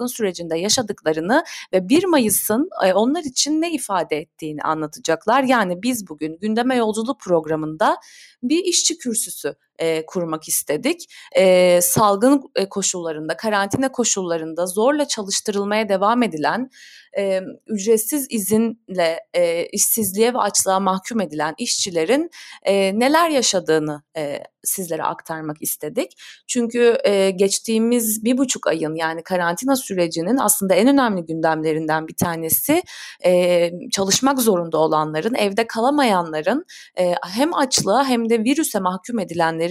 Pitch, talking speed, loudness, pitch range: 205 Hz, 115 wpm, -19 LUFS, 170-250 Hz